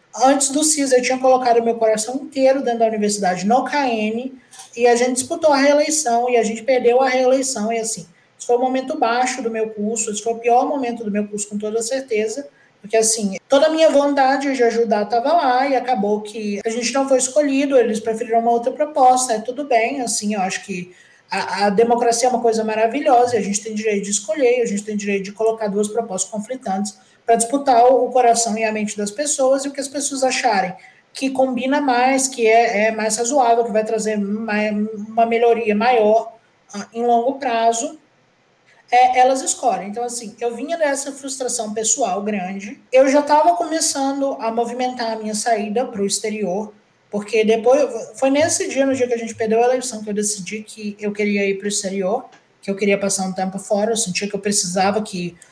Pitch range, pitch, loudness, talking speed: 215-260 Hz, 235 Hz, -18 LUFS, 210 wpm